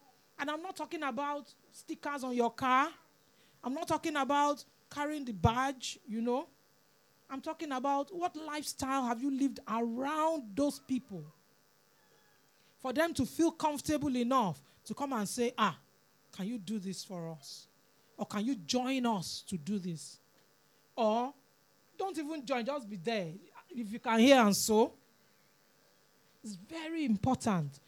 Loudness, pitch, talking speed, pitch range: -34 LUFS, 260 Hz, 150 wpm, 220-290 Hz